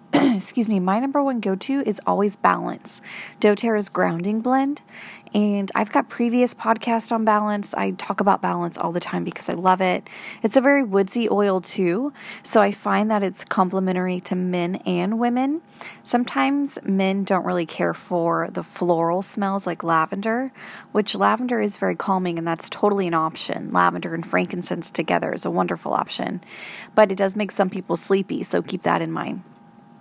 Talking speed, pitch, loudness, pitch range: 175 wpm, 200 Hz, -22 LUFS, 185-225 Hz